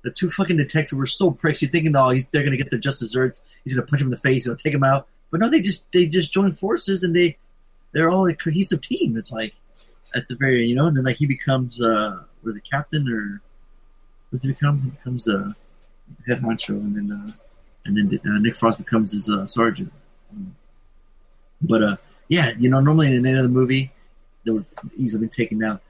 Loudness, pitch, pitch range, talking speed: -21 LUFS, 135 Hz, 120-165 Hz, 235 wpm